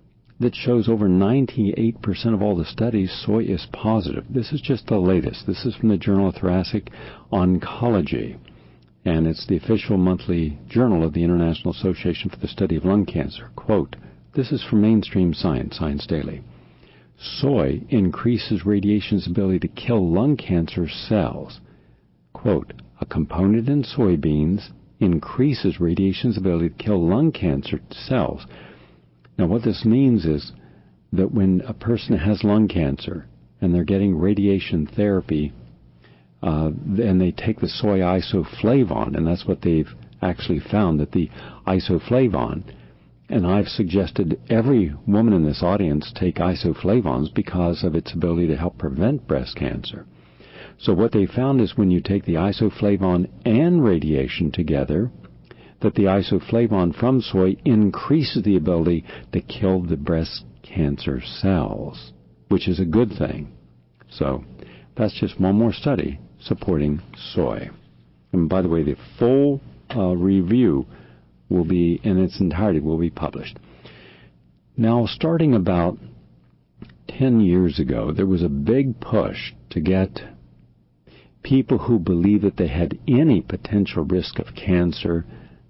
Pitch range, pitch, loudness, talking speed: 75-105 Hz, 90 Hz, -21 LUFS, 140 wpm